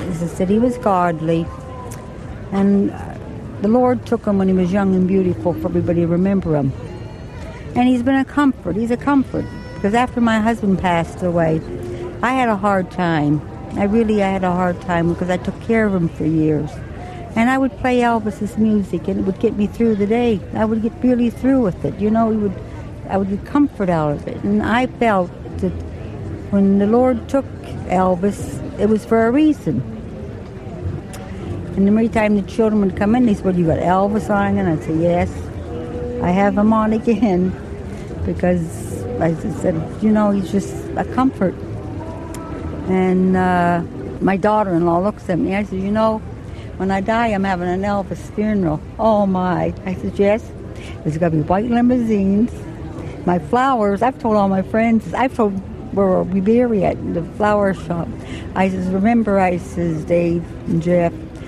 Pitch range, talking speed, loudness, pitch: 170-220 Hz, 185 wpm, -18 LUFS, 195 Hz